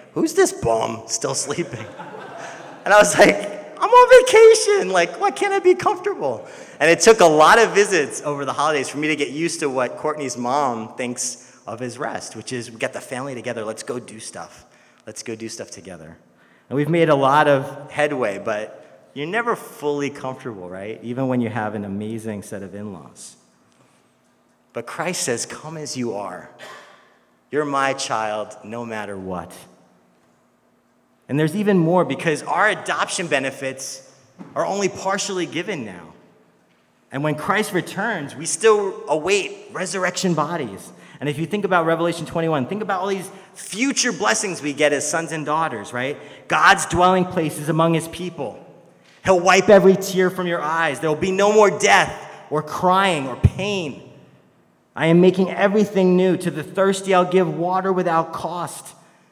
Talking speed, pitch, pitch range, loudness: 170 wpm, 155 Hz, 125-190 Hz, -19 LUFS